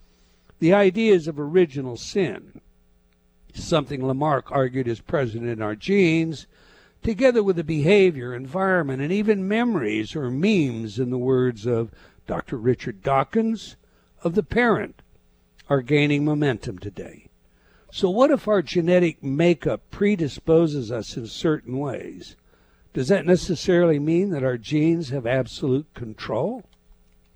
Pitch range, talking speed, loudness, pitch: 115-175 Hz, 125 wpm, -22 LUFS, 140 Hz